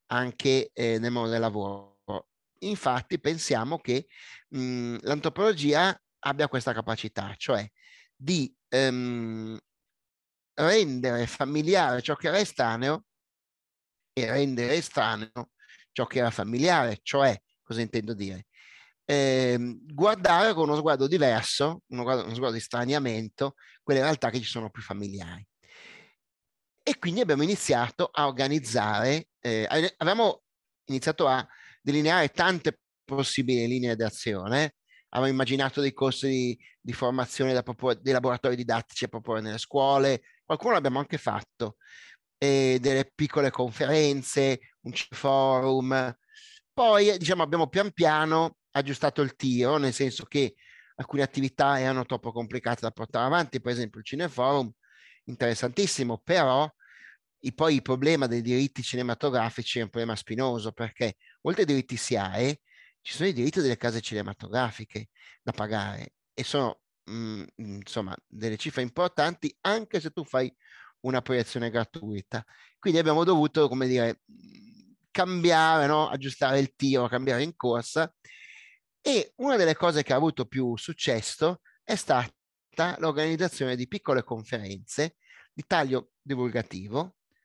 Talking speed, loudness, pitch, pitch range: 130 wpm, -27 LUFS, 130 Hz, 120-150 Hz